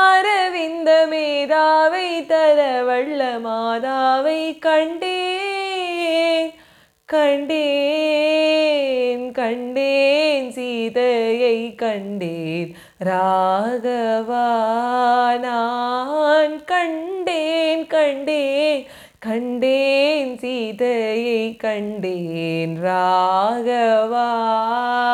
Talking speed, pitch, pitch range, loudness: 40 wpm, 255 Hz, 230-310 Hz, -19 LUFS